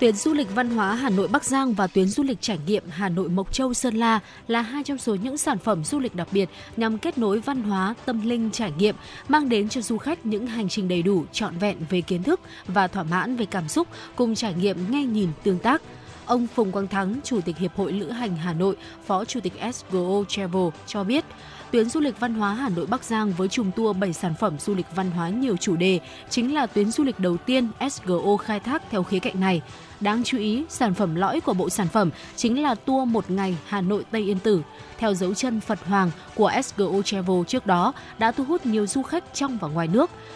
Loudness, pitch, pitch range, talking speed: -24 LUFS, 210 Hz, 190-245 Hz, 245 wpm